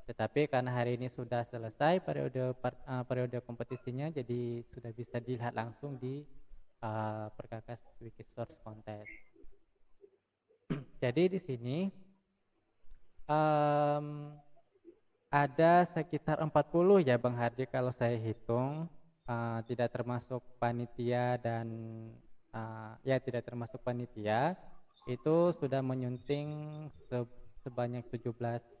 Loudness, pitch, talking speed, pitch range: -35 LUFS, 125 Hz, 105 wpm, 120-150 Hz